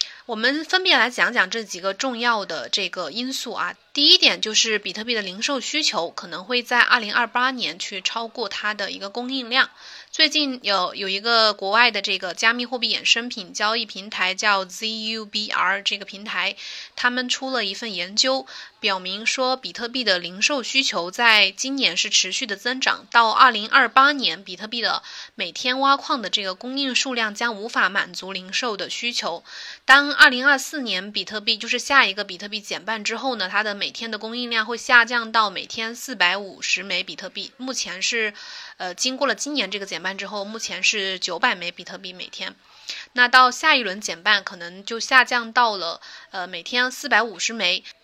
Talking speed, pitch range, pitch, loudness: 290 characters per minute, 195-255 Hz, 225 Hz, -20 LUFS